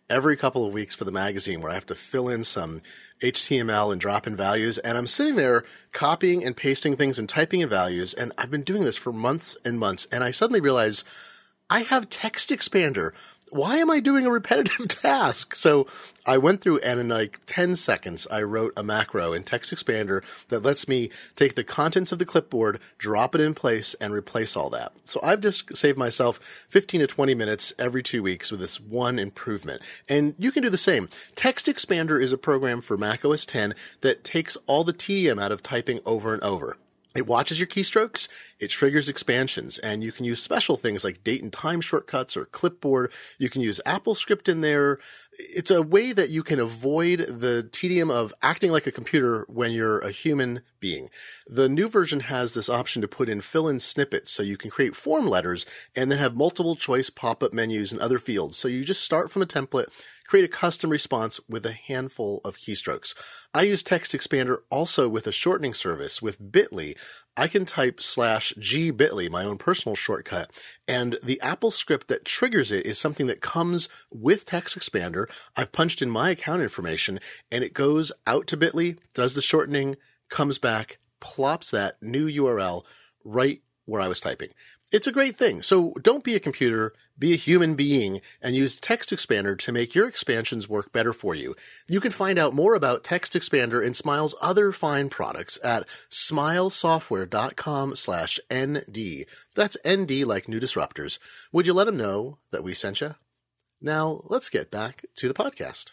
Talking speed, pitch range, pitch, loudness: 195 wpm, 115-180 Hz, 140 Hz, -24 LUFS